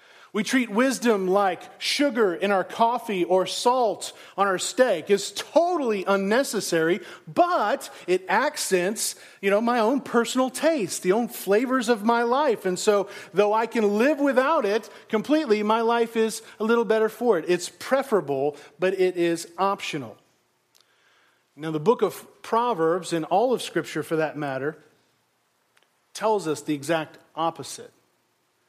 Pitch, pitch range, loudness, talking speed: 205 Hz, 175-235 Hz, -24 LUFS, 150 wpm